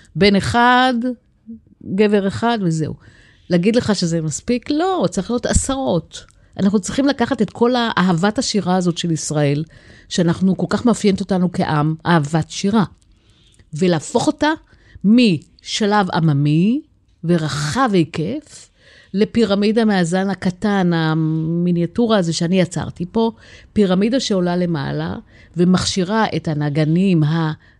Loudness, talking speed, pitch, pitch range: -18 LUFS, 110 wpm, 190 Hz, 165-225 Hz